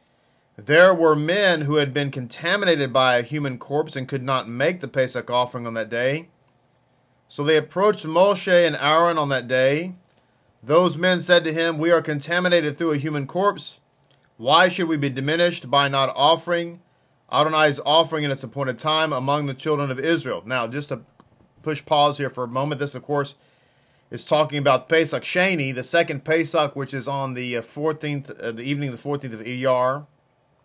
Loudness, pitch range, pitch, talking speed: -21 LUFS, 130-160 Hz, 145 Hz, 185 wpm